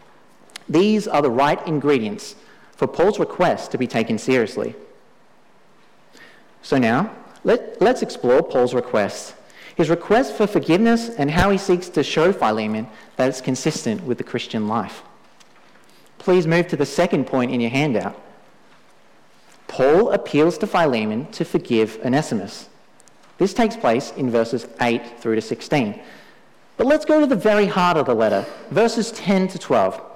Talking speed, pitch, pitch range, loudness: 150 wpm, 170 Hz, 130-210 Hz, -20 LUFS